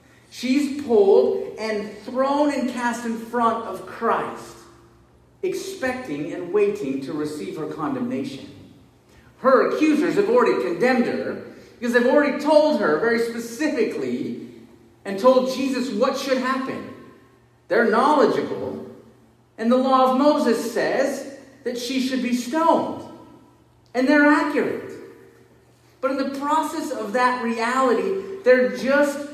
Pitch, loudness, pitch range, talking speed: 265 Hz, -21 LUFS, 245-310 Hz, 125 wpm